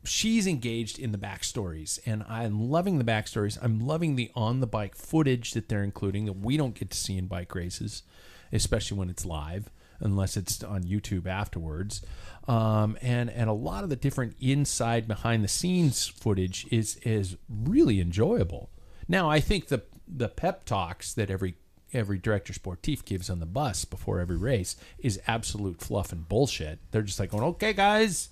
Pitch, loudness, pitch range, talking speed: 110 Hz, -29 LUFS, 95-125 Hz, 170 wpm